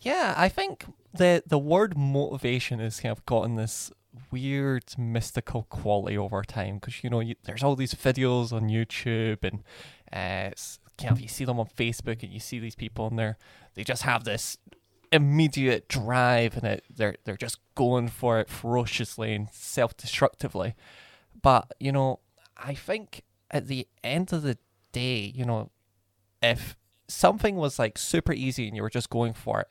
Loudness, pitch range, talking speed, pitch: -28 LUFS, 110-130 Hz, 180 wpm, 120 Hz